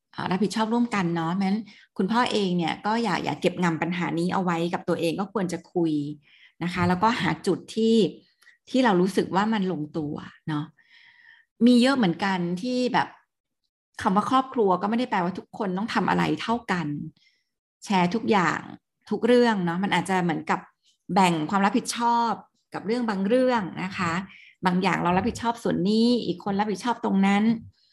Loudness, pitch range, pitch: -25 LUFS, 175-230 Hz, 195 Hz